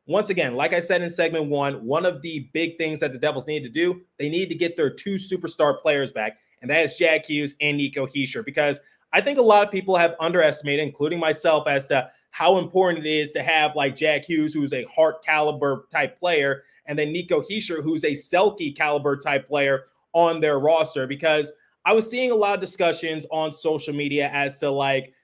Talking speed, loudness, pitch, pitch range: 215 wpm, -22 LUFS, 155 Hz, 145-170 Hz